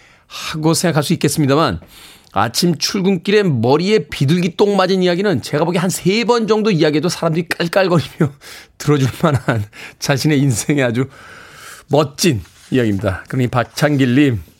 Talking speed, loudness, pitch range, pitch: 340 characters per minute, -16 LUFS, 130-180 Hz, 150 Hz